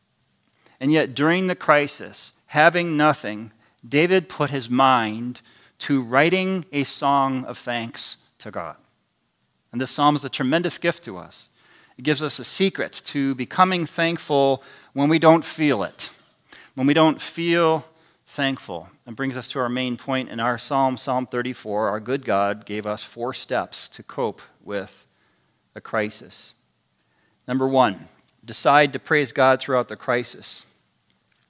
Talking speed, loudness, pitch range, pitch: 150 wpm, -22 LUFS, 125-150 Hz, 135 Hz